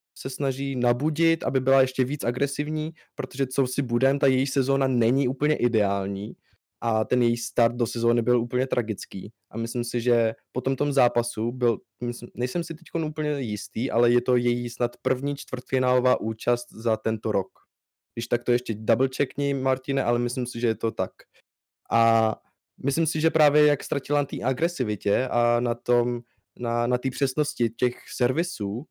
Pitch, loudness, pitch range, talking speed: 125 Hz, -25 LUFS, 115-135 Hz, 170 wpm